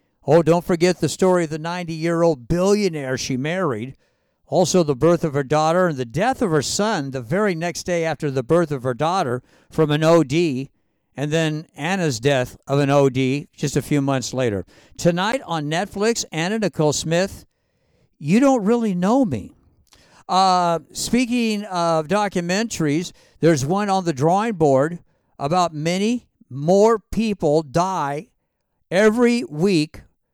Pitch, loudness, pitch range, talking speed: 170 Hz, -20 LUFS, 145-190 Hz, 155 wpm